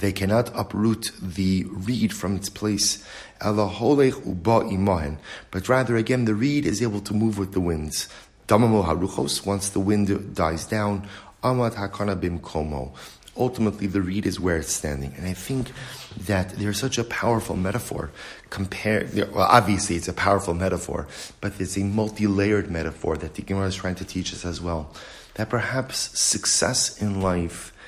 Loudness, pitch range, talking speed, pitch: -24 LUFS, 90-110 Hz, 145 wpm, 100 Hz